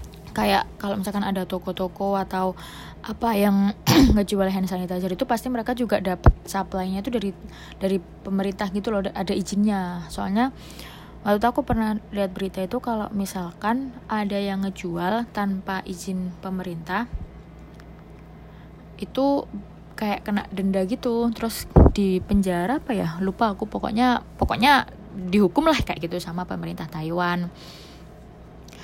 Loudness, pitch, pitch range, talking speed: -24 LUFS, 195 Hz, 185-220 Hz, 125 wpm